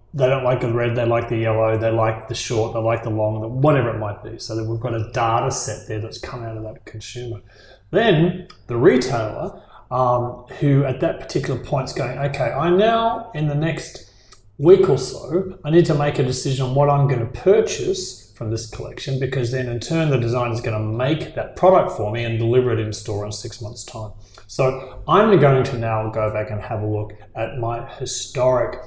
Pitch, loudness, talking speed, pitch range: 120 Hz, -20 LUFS, 220 wpm, 110-140 Hz